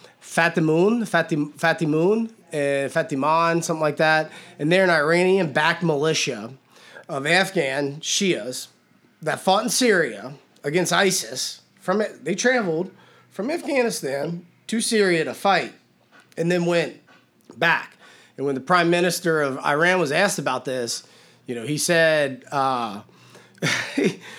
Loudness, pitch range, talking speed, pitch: -21 LUFS, 145-180 Hz, 125 wpm, 165 Hz